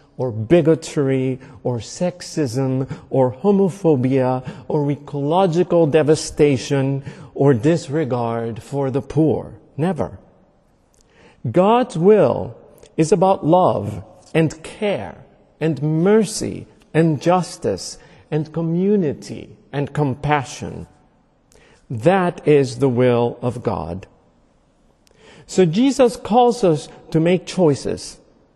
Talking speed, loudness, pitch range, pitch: 90 wpm, -19 LUFS, 135-180 Hz, 150 Hz